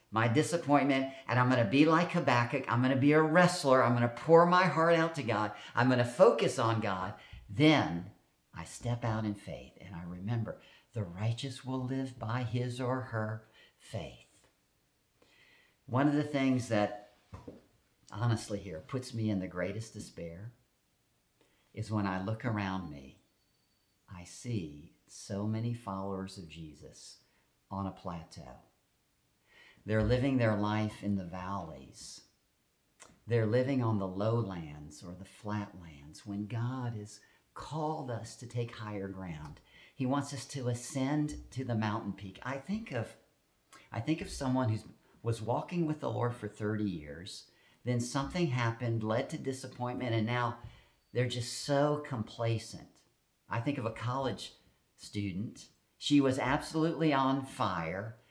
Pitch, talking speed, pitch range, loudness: 115 Hz, 150 wpm, 100-130 Hz, -33 LUFS